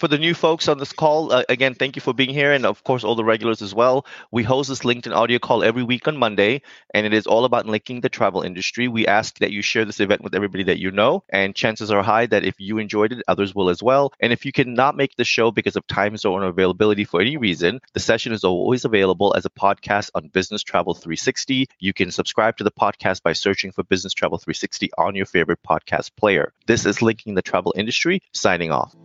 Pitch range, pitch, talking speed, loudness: 100-130 Hz, 110 Hz, 245 wpm, -20 LUFS